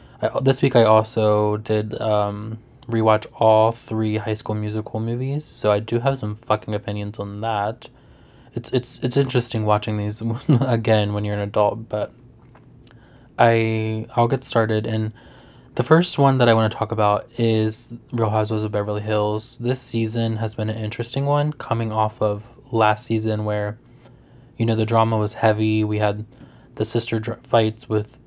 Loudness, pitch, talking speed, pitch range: -21 LUFS, 110 Hz, 170 wpm, 105-120 Hz